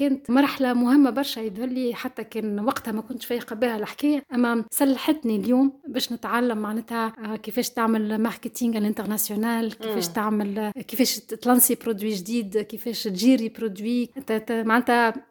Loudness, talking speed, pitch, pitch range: -24 LUFS, 130 wpm, 230 Hz, 220-250 Hz